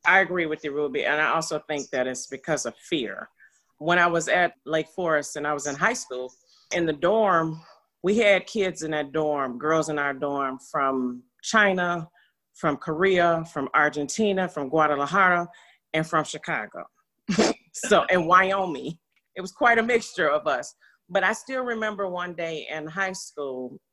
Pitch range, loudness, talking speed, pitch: 150-185 Hz, -24 LUFS, 175 wpm, 160 Hz